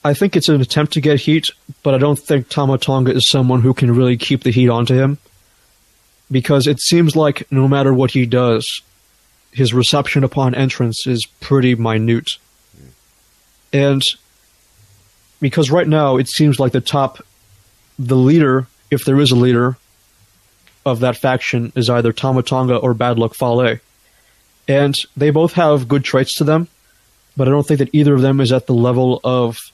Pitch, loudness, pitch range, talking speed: 130 Hz, -15 LUFS, 120-140 Hz, 175 wpm